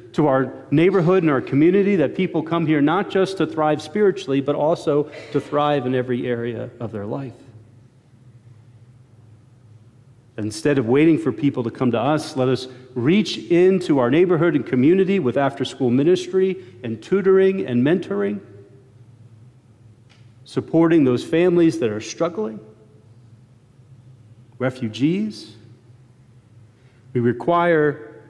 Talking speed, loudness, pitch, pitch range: 125 wpm, -20 LUFS, 130 Hz, 120-160 Hz